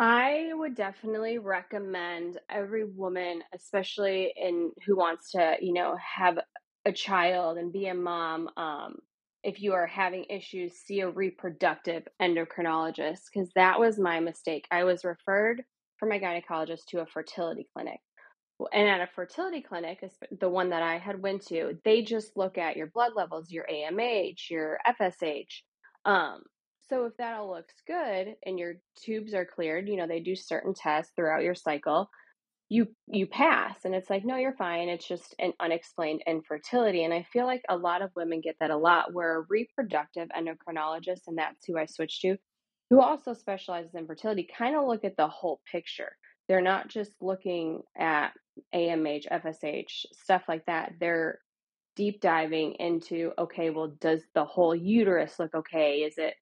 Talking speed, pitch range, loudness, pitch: 170 wpm, 165-200 Hz, -30 LUFS, 180 Hz